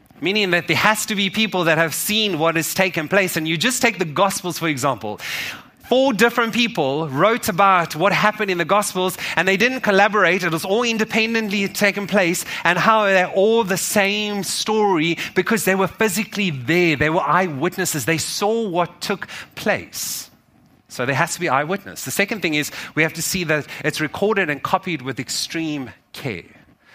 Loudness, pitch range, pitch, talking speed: -19 LUFS, 165-210 Hz, 190 Hz, 190 wpm